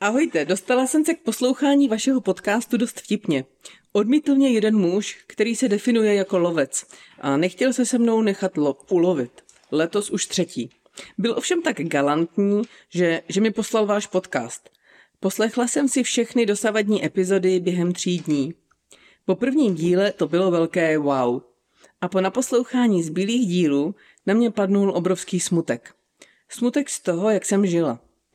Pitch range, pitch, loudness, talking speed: 175-235 Hz, 200 Hz, -21 LUFS, 150 wpm